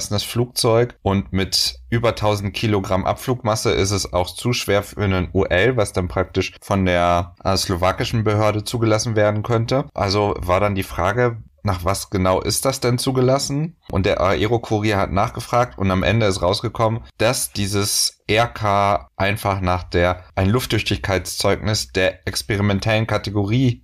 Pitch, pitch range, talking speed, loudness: 100 Hz, 95-115 Hz, 150 wpm, -20 LUFS